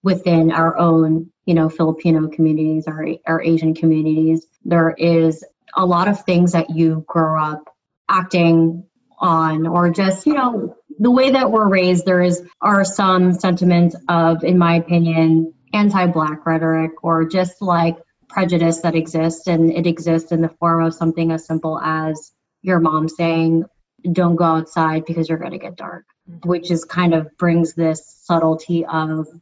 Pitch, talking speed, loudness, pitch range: 165 Hz, 165 wpm, -17 LUFS, 160-180 Hz